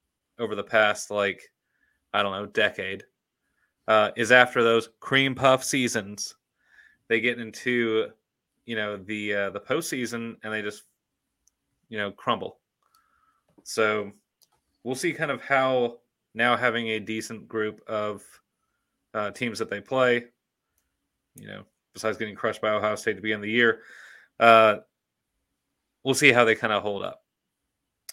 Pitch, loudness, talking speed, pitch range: 110 Hz, -25 LUFS, 145 wpm, 105-120 Hz